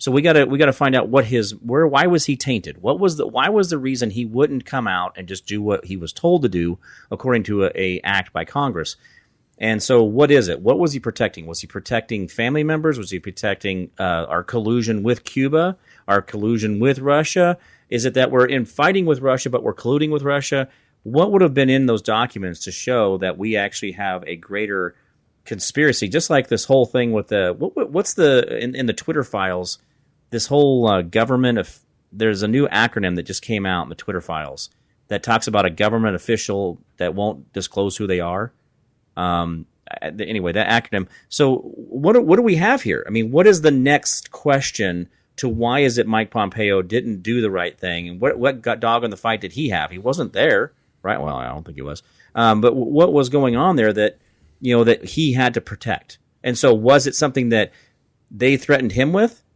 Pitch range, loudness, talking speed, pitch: 100-140 Hz, -19 LUFS, 220 wpm, 115 Hz